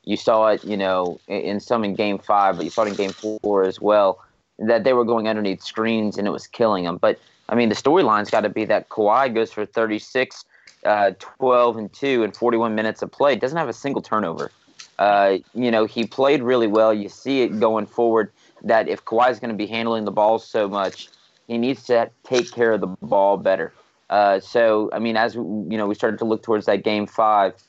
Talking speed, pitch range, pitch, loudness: 230 wpm, 105-115 Hz, 110 Hz, -20 LUFS